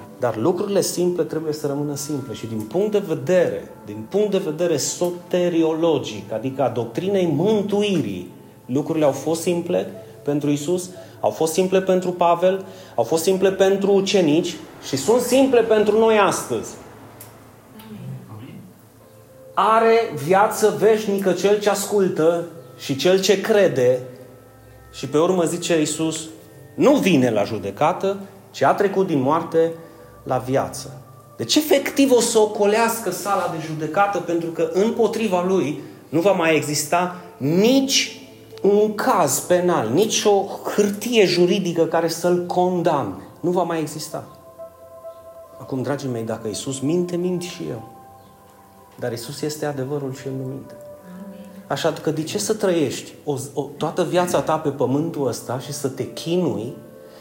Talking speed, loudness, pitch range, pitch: 145 wpm, -20 LUFS, 135-195 Hz, 165 Hz